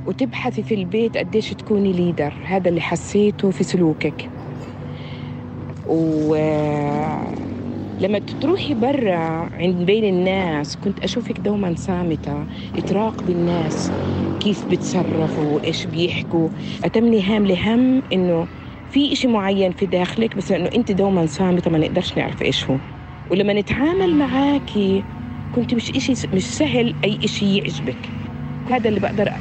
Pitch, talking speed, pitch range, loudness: 185 Hz, 125 wpm, 160-215 Hz, -20 LUFS